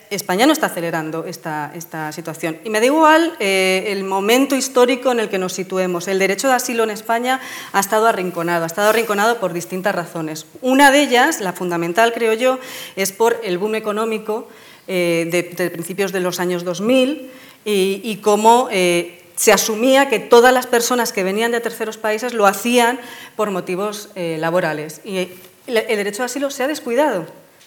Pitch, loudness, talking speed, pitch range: 210 Hz, -17 LUFS, 180 wpm, 180-240 Hz